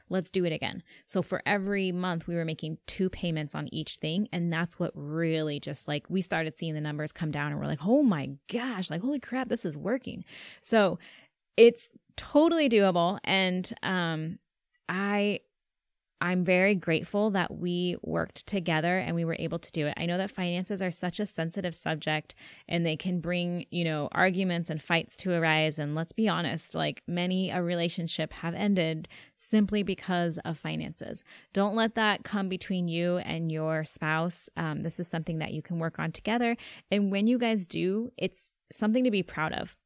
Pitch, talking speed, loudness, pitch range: 175 Hz, 190 wpm, -29 LUFS, 165-200 Hz